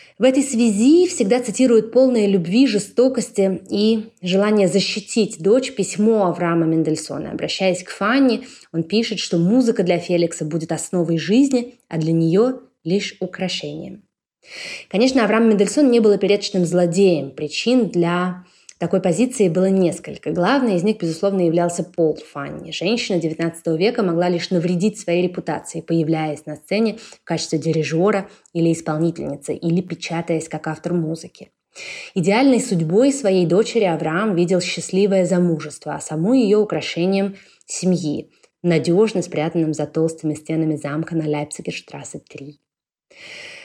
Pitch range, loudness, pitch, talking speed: 165-215 Hz, -19 LUFS, 180 Hz, 130 wpm